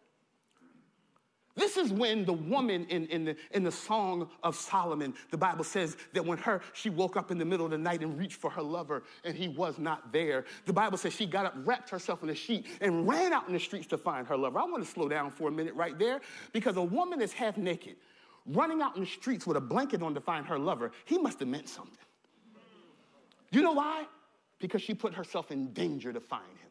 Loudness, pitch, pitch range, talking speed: -33 LUFS, 185 Hz, 165-220 Hz, 235 wpm